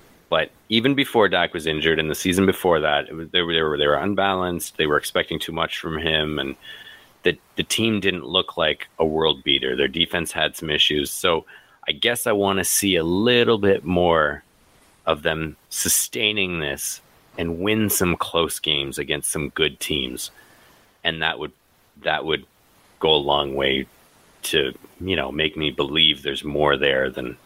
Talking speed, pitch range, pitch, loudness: 180 wpm, 75-95 Hz, 80 Hz, -21 LUFS